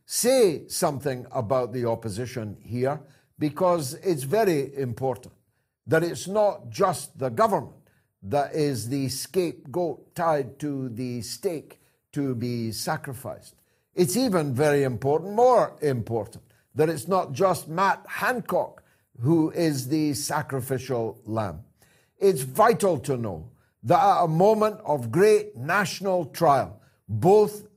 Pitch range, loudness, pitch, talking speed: 125-180 Hz, -25 LUFS, 145 Hz, 125 wpm